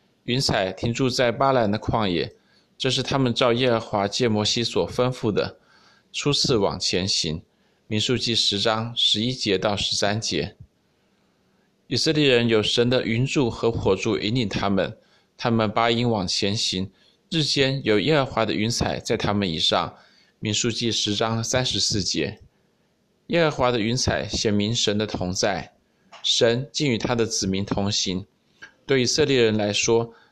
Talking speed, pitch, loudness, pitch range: 230 characters per minute, 115 Hz, -22 LUFS, 105-125 Hz